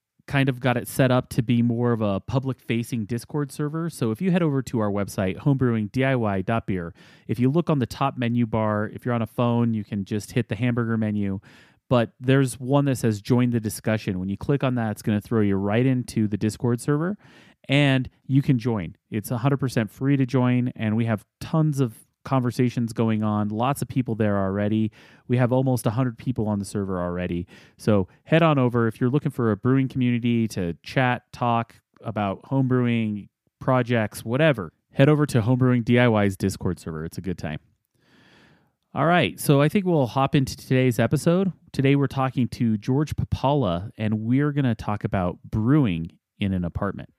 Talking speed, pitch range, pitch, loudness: 195 wpm, 110-135 Hz, 120 Hz, -24 LUFS